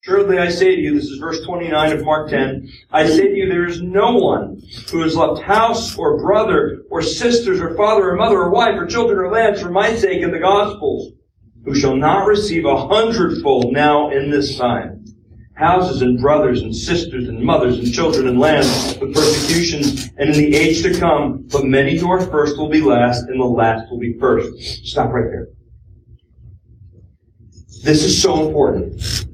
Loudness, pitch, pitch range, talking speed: -16 LUFS, 150 Hz, 125-185 Hz, 190 wpm